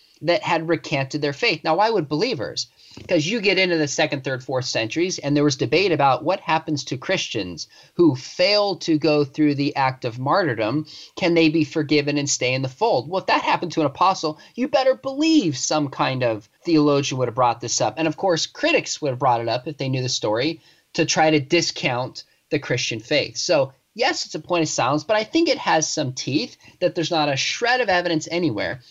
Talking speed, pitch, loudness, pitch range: 220 wpm, 155 Hz, -21 LUFS, 140-170 Hz